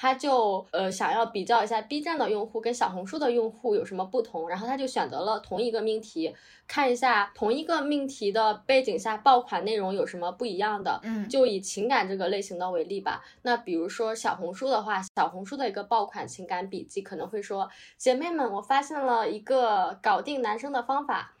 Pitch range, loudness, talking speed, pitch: 200-260 Hz, -28 LUFS, 320 characters per minute, 225 Hz